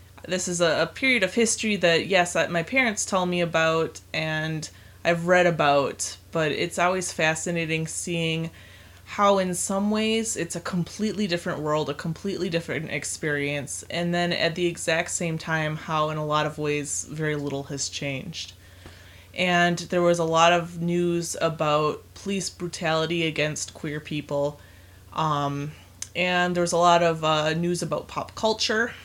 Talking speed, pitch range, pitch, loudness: 160 wpm, 150-175 Hz, 165 Hz, -24 LUFS